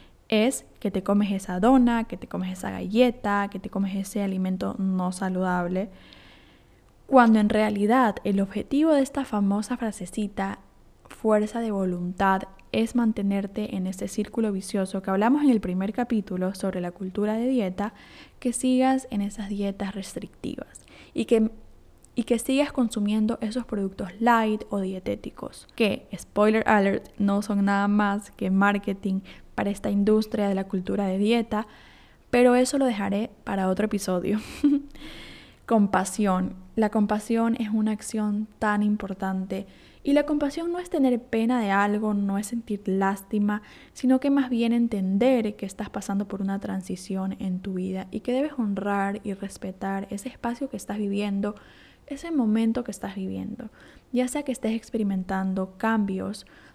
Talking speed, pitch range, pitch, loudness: 155 wpm, 195-235 Hz, 210 Hz, -26 LUFS